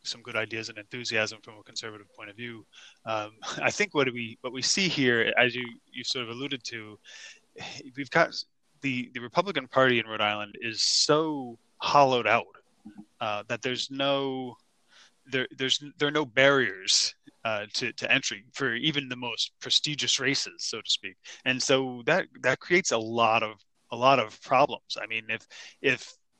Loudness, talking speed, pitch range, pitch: -27 LUFS, 180 wpm, 110-140 Hz, 125 Hz